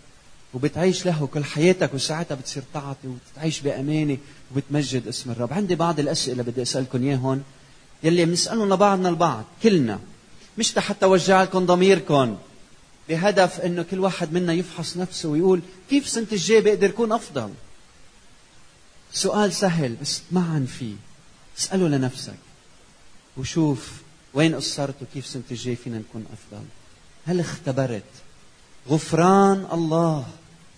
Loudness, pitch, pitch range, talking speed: -22 LUFS, 155 Hz, 135-180 Hz, 120 wpm